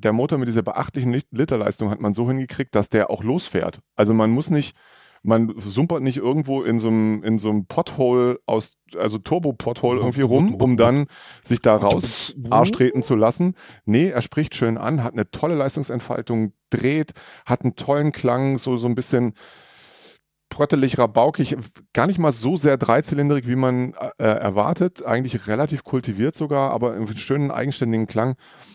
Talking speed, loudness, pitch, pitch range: 175 wpm, -21 LUFS, 125 Hz, 115-140 Hz